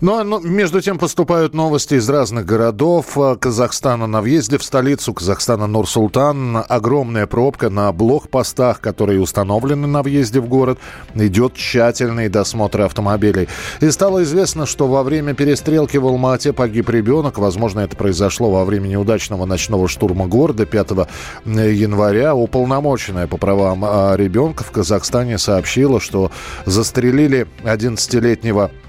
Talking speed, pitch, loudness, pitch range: 125 wpm, 115 Hz, -16 LUFS, 105-140 Hz